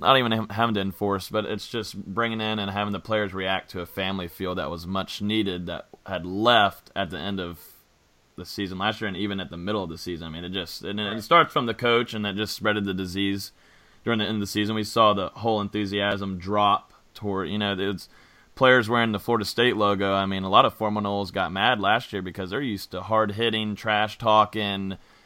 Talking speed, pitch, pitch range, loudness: 235 wpm, 100 Hz, 95-110 Hz, -25 LUFS